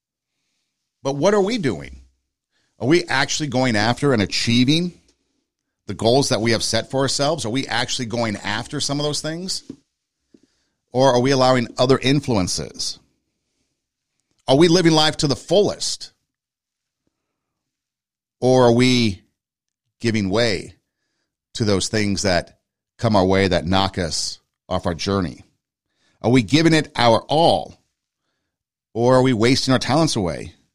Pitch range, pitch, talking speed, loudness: 100-140 Hz, 120 Hz, 140 wpm, -19 LUFS